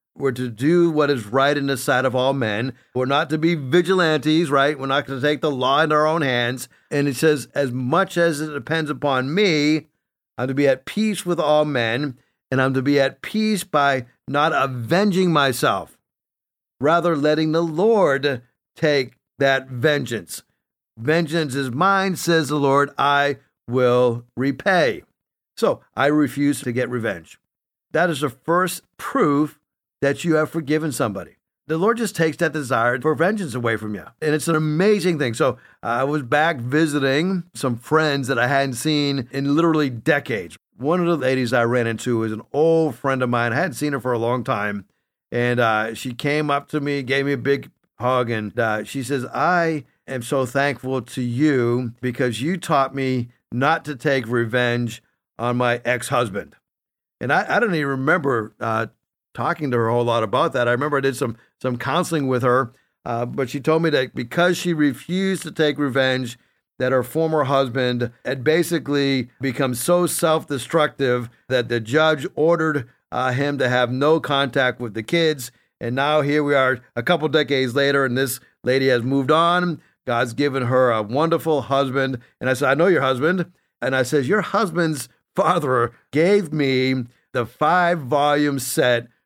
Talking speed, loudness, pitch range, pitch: 180 wpm, -20 LUFS, 125-155 Hz, 140 Hz